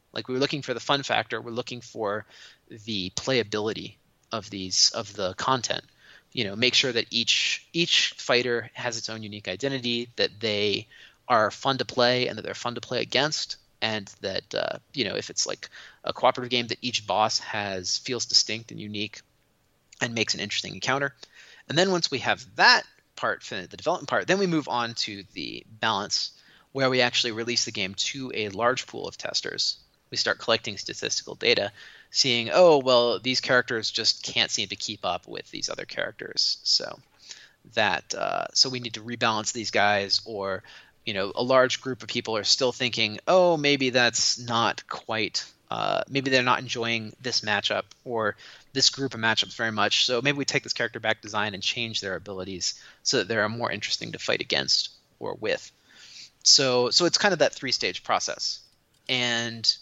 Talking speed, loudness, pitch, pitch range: 190 wpm, -25 LUFS, 120 Hz, 110-130 Hz